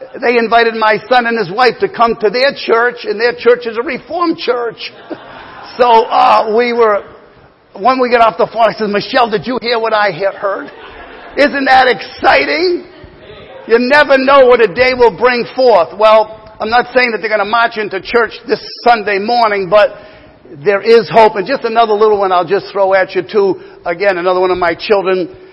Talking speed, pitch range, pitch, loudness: 200 wpm, 210-250 Hz, 230 Hz, -11 LUFS